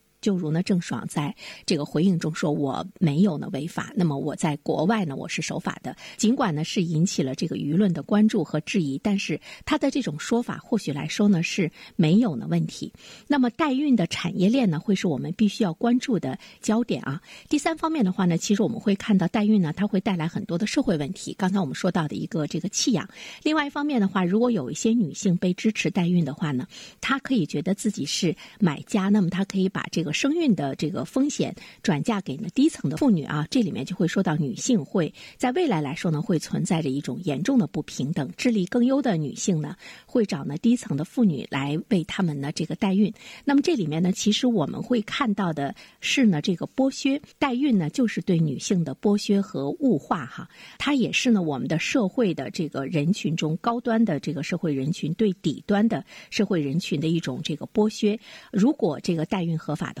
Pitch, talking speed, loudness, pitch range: 195 Hz, 320 characters per minute, -25 LUFS, 160-230 Hz